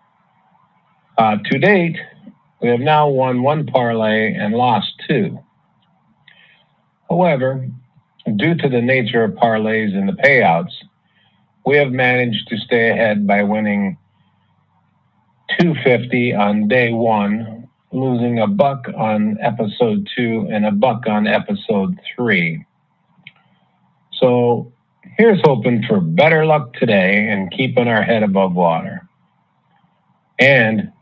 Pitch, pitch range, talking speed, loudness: 125 Hz, 110-155 Hz, 115 wpm, -16 LUFS